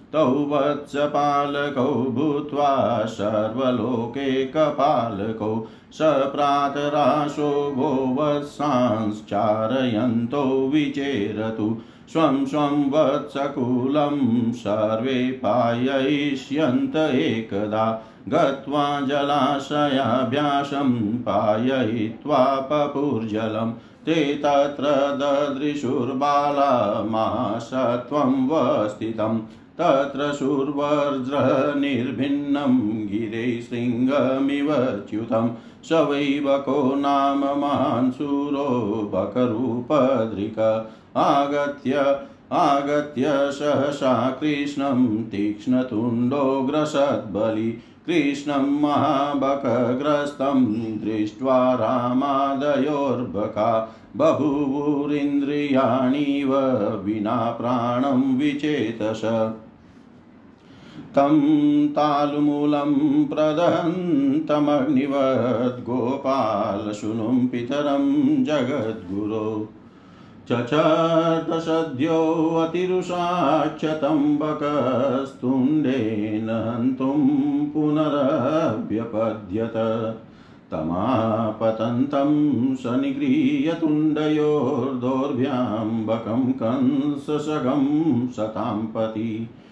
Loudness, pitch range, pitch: -22 LUFS, 115-145 Hz, 140 Hz